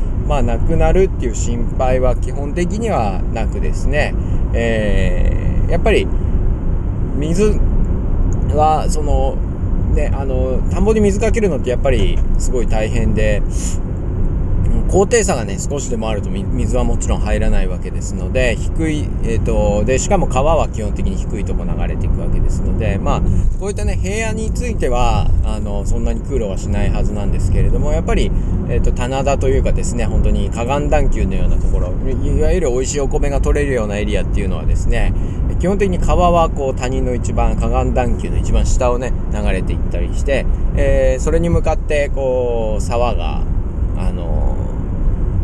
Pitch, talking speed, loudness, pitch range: 95 Hz, 340 characters per minute, -18 LUFS, 90-115 Hz